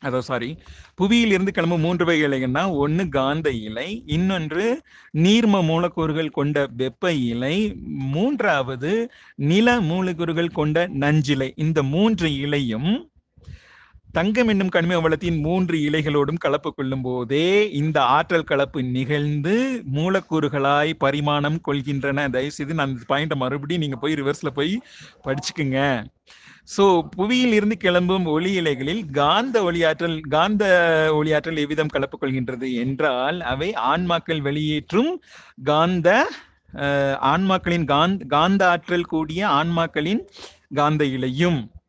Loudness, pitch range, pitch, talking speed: -21 LUFS, 140-180 Hz, 155 Hz, 110 wpm